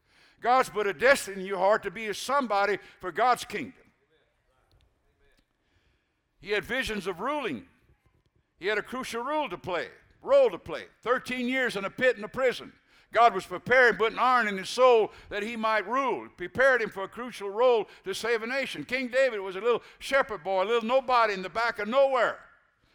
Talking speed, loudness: 195 wpm, -27 LUFS